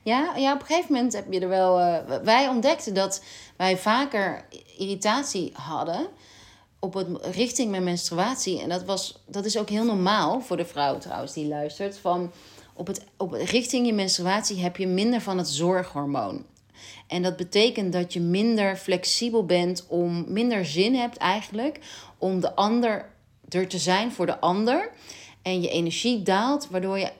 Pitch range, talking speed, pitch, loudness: 175-225 Hz, 170 wpm, 190 Hz, -25 LUFS